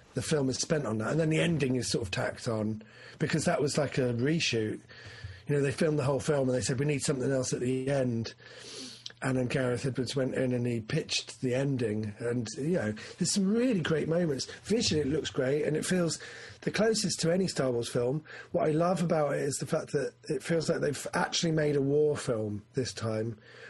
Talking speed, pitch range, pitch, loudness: 230 wpm, 120-160 Hz, 140 Hz, -30 LUFS